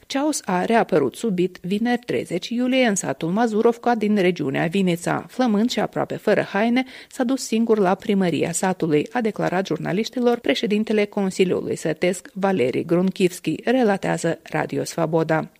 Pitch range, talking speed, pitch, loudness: 175-235 Hz, 135 wpm, 200 Hz, -21 LUFS